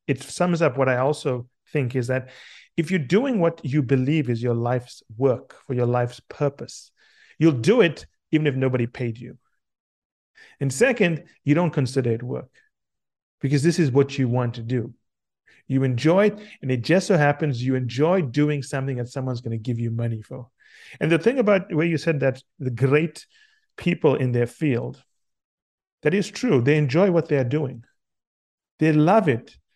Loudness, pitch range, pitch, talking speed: -22 LUFS, 125-165 Hz, 140 Hz, 185 wpm